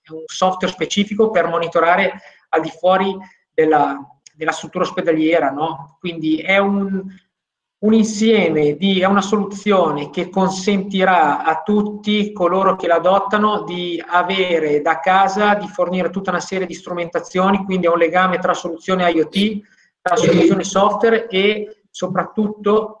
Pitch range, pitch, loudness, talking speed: 170-200 Hz, 185 Hz, -17 LUFS, 135 wpm